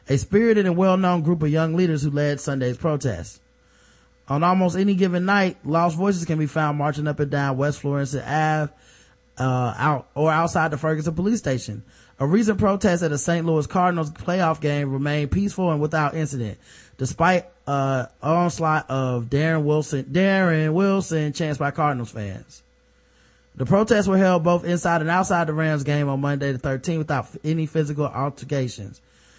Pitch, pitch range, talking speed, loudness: 150 Hz, 135-175 Hz, 175 wpm, -22 LUFS